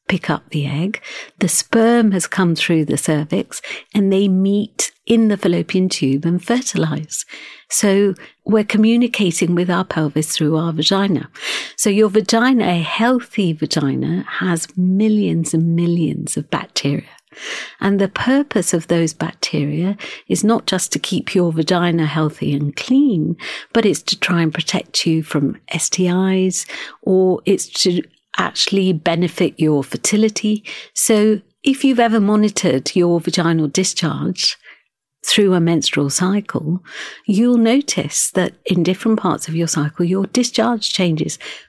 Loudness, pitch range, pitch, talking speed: -17 LUFS, 165-210 Hz, 185 Hz, 140 wpm